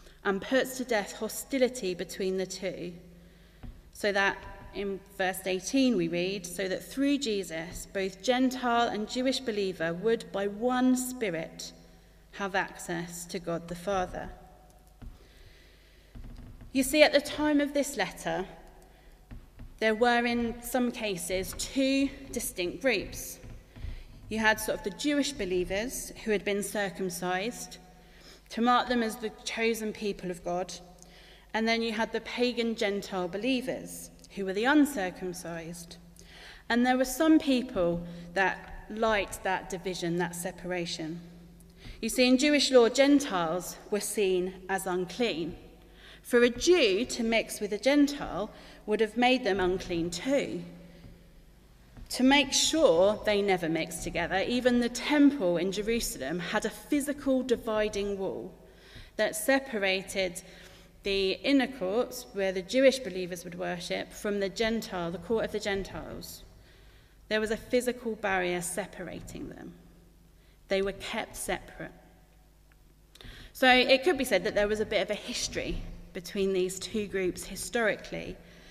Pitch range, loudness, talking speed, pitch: 180-240 Hz, -29 LUFS, 140 wpm, 200 Hz